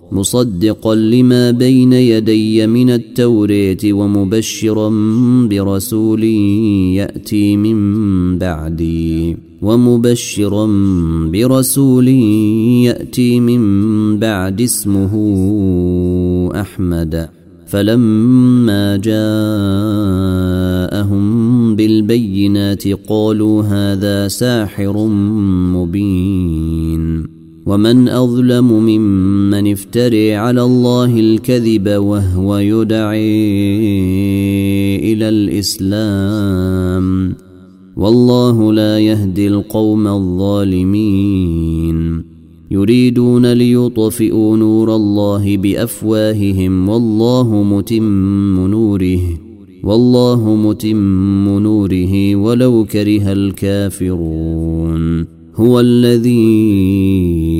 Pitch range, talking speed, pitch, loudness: 95-110 Hz, 60 wpm, 105 Hz, -12 LUFS